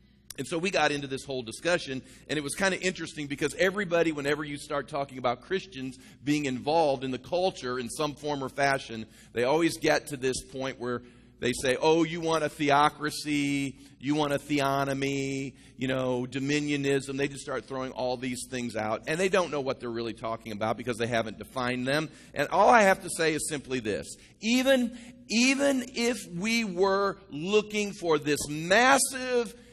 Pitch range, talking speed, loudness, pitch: 130-170 Hz, 190 wpm, -28 LUFS, 145 Hz